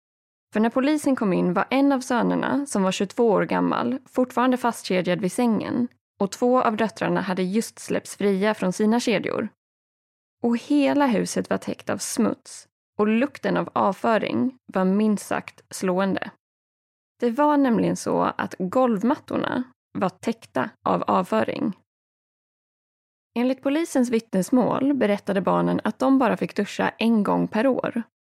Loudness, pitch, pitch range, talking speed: -23 LUFS, 235 Hz, 200-260 Hz, 145 wpm